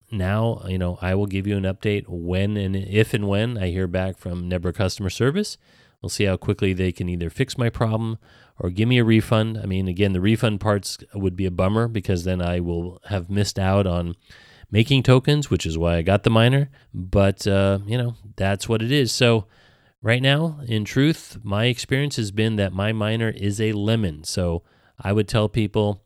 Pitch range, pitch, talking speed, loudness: 95-115 Hz, 105 Hz, 210 wpm, -22 LUFS